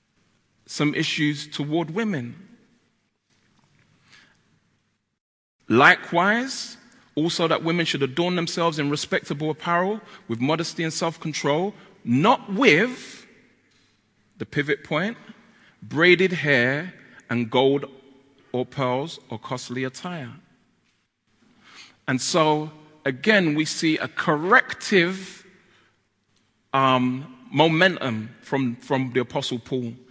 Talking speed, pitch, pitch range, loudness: 95 wpm, 155 Hz, 130-180 Hz, -22 LUFS